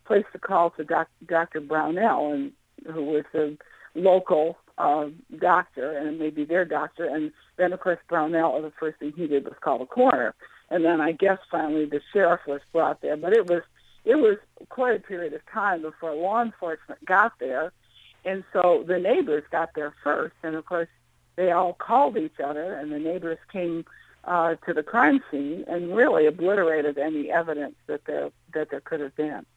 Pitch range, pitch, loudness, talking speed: 150-180 Hz, 165 Hz, -25 LUFS, 190 wpm